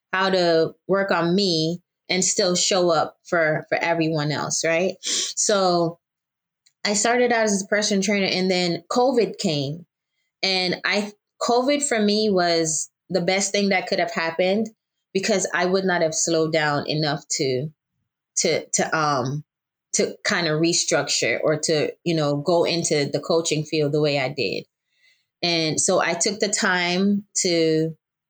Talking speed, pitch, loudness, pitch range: 160 wpm, 175 Hz, -21 LUFS, 160-200 Hz